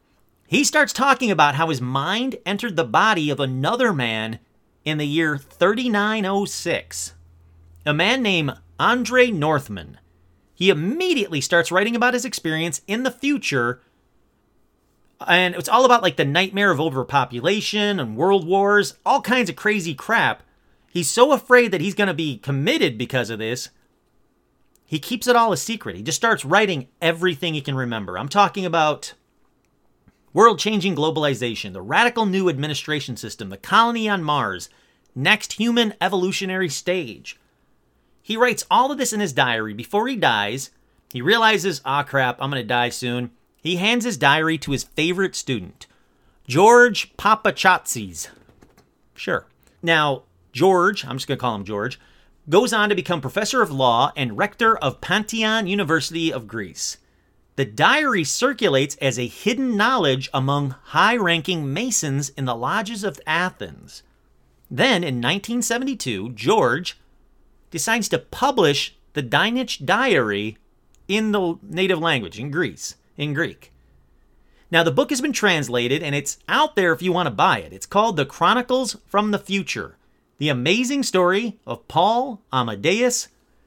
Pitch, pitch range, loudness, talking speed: 170 Hz, 130-210 Hz, -20 LUFS, 150 wpm